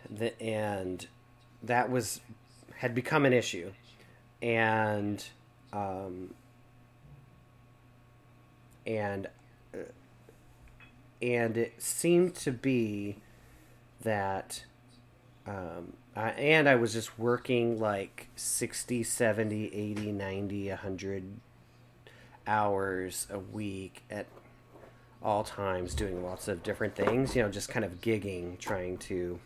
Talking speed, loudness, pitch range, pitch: 100 wpm, -32 LUFS, 100-120 Hz, 115 Hz